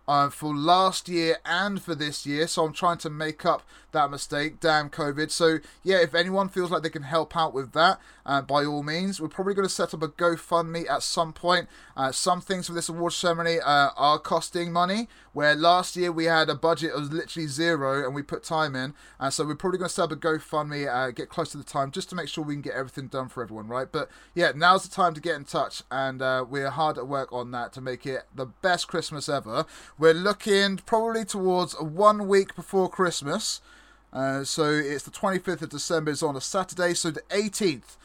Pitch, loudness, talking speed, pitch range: 160 Hz, -26 LUFS, 230 wpm, 145-180 Hz